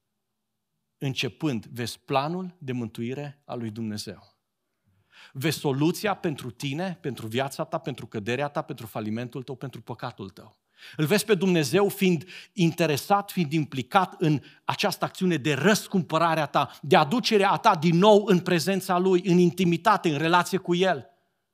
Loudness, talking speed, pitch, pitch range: -25 LUFS, 145 wpm, 160 Hz, 125-185 Hz